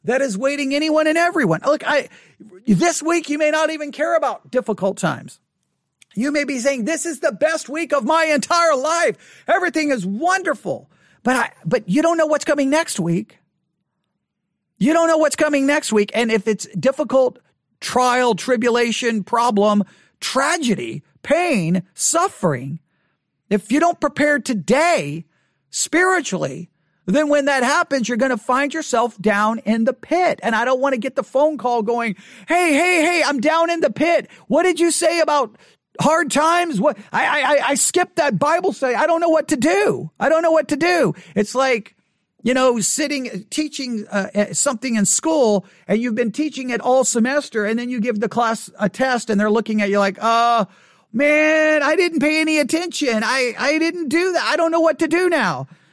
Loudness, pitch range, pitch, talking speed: -18 LUFS, 215-315 Hz, 265 Hz, 190 wpm